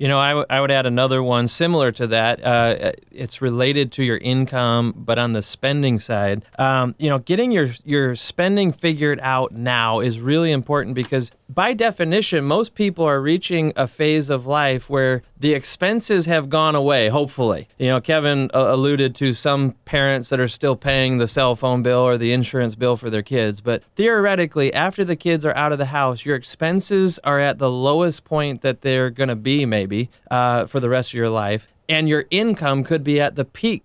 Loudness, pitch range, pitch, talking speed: -19 LUFS, 125-155 Hz, 135 Hz, 205 wpm